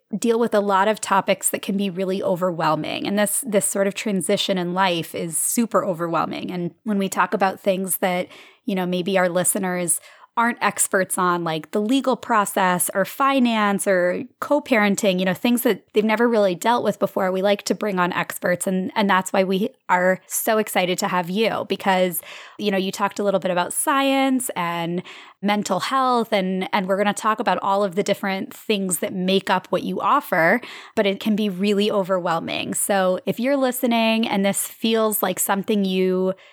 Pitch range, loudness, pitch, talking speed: 185-215 Hz, -21 LUFS, 195 Hz, 195 wpm